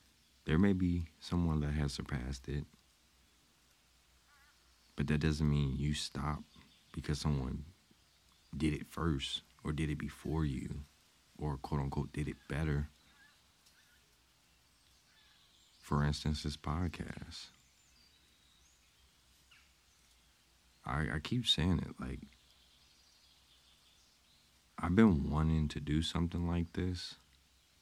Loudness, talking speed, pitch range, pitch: -36 LUFS, 105 wpm, 70-80 Hz, 75 Hz